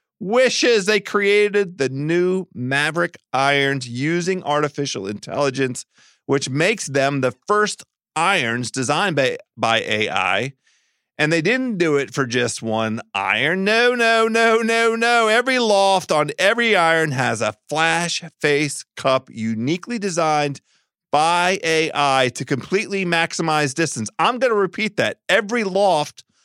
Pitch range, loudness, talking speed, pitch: 140-205 Hz, -19 LUFS, 135 wpm, 160 Hz